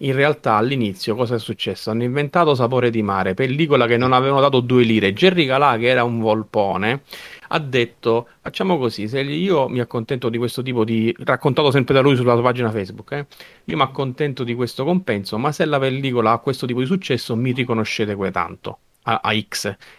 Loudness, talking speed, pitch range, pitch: -19 LUFS, 200 wpm, 115-140 Hz, 125 Hz